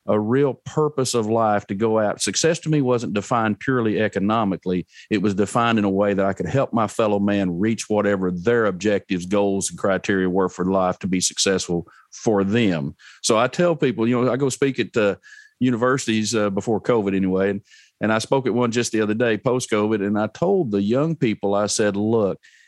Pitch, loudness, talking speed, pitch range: 105 Hz, -21 LUFS, 215 wpm, 100-120 Hz